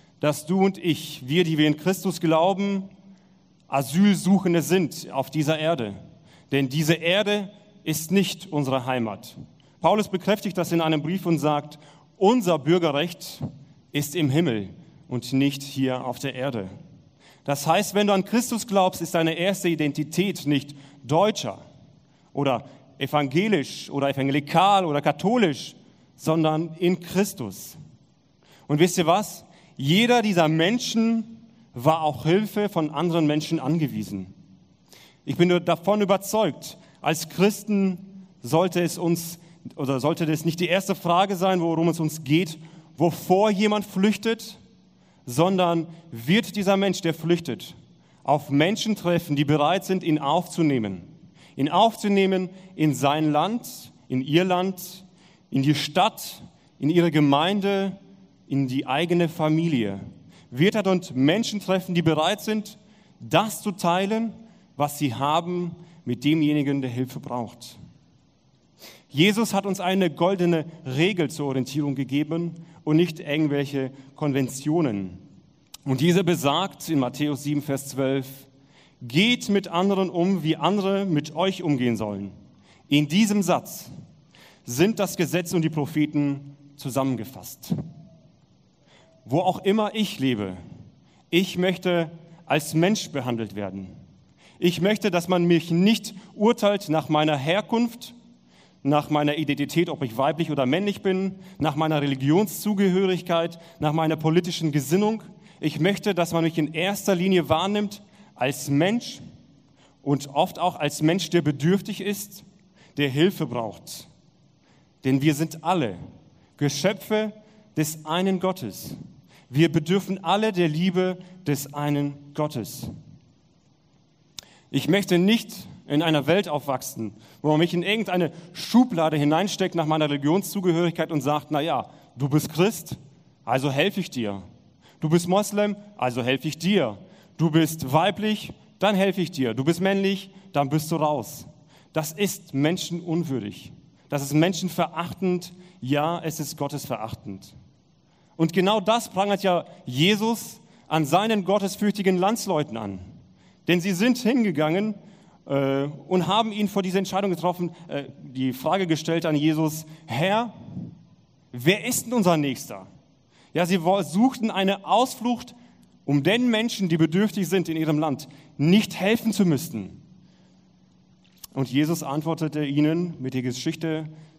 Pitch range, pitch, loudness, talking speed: 145-190 Hz, 165 Hz, -24 LUFS, 135 wpm